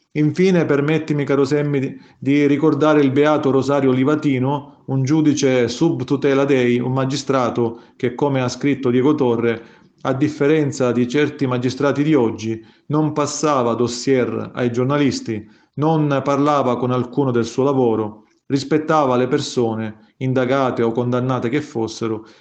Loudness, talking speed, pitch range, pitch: -18 LUFS, 130 wpm, 125-145 Hz, 135 Hz